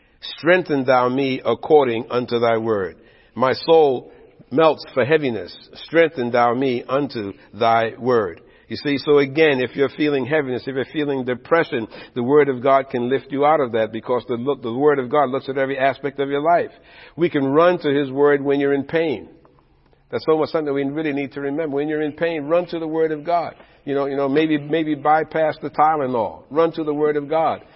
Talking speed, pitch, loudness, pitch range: 210 wpm, 140 Hz, -19 LUFS, 130-155 Hz